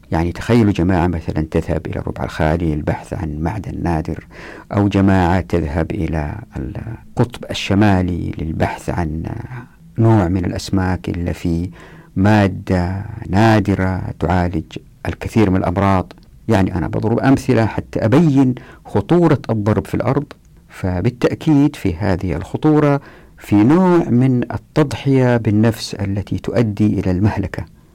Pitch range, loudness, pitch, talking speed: 90-115 Hz, -17 LUFS, 100 Hz, 115 wpm